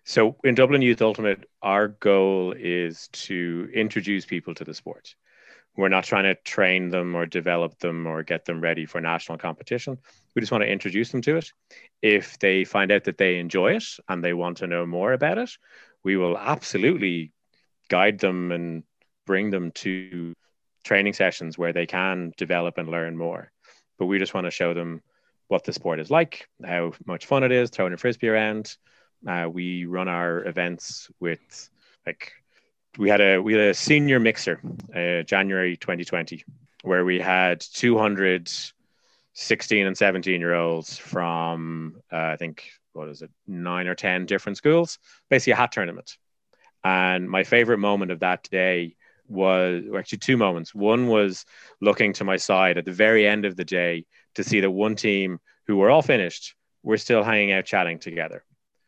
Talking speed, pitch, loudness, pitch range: 180 wpm, 95 Hz, -23 LUFS, 85-105 Hz